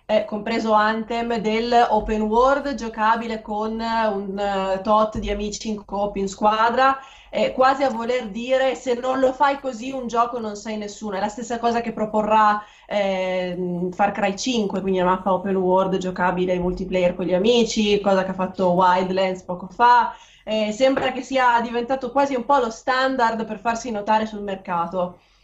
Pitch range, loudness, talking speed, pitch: 195-240 Hz, -21 LUFS, 175 wpm, 215 Hz